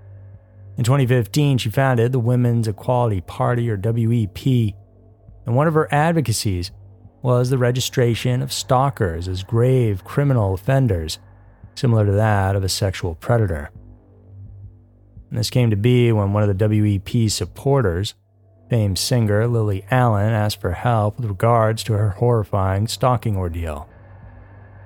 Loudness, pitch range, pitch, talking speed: -19 LUFS, 100-120 Hz, 110 Hz, 135 wpm